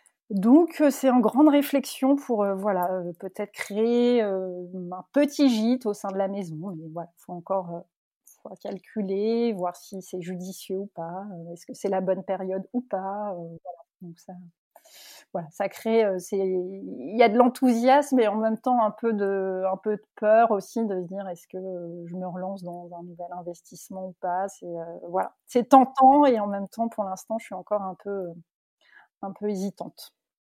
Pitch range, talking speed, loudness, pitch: 180-230 Hz, 200 wpm, -25 LUFS, 195 Hz